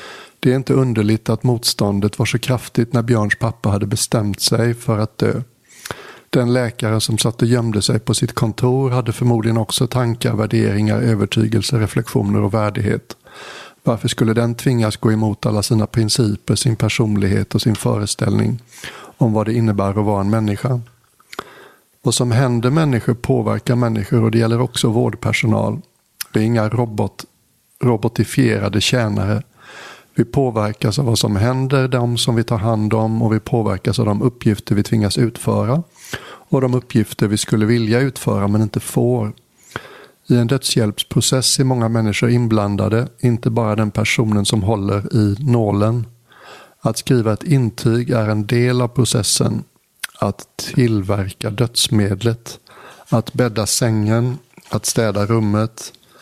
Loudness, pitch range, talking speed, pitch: -17 LUFS, 110-125 Hz, 150 wpm, 115 Hz